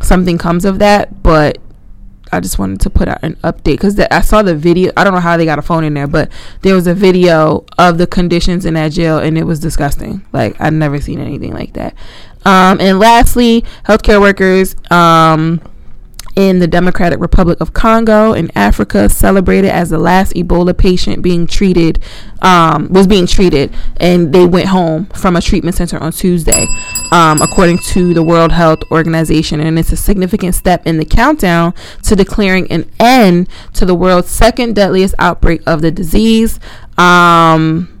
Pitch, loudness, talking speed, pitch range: 175 Hz, -10 LUFS, 180 wpm, 160-190 Hz